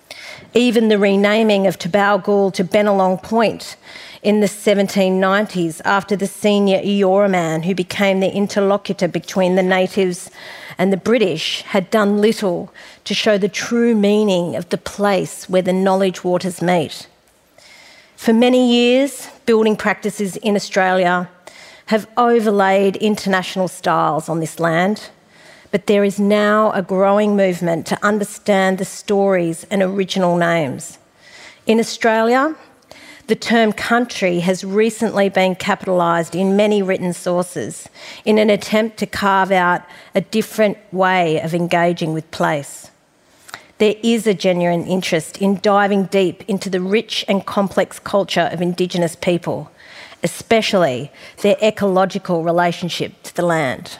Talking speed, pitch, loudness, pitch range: 135 wpm, 195 Hz, -17 LUFS, 180-210 Hz